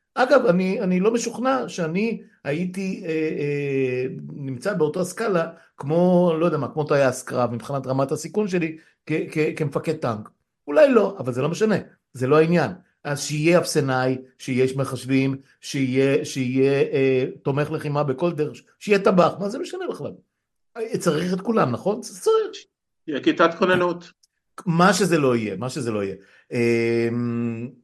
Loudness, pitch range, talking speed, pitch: -22 LUFS, 135-190 Hz, 135 wpm, 160 Hz